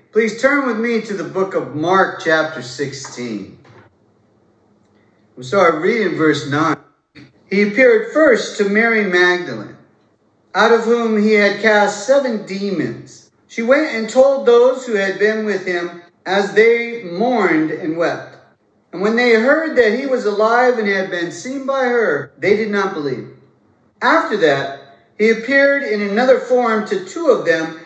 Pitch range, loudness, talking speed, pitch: 160-235 Hz, -15 LUFS, 160 wpm, 205 Hz